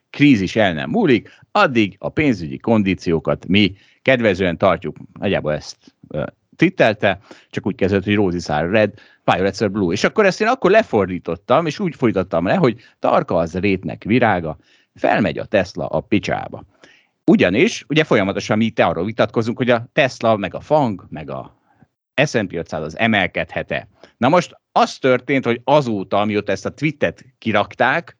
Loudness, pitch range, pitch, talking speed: -18 LUFS, 95-125 Hz, 105 Hz, 155 wpm